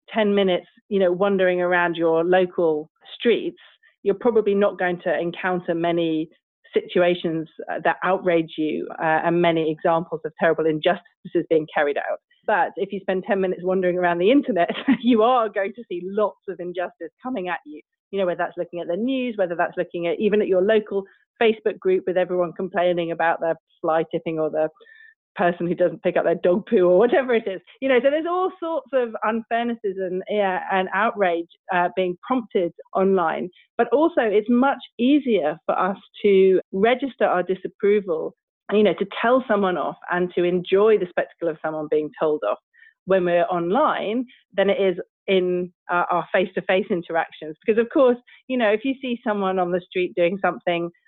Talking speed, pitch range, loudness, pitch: 190 wpm, 175-220 Hz, -22 LUFS, 185 Hz